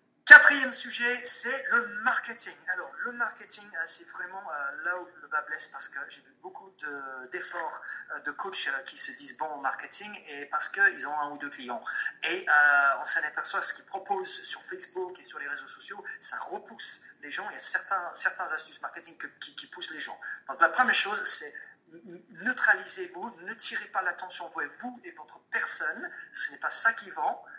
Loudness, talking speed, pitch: -26 LUFS, 195 wpm, 210 Hz